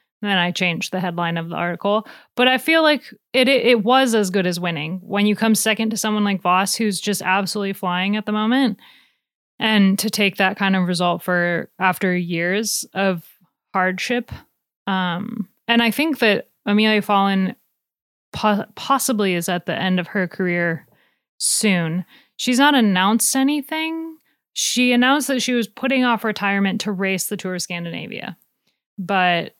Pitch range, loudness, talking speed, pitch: 185-235 Hz, -19 LUFS, 170 wpm, 205 Hz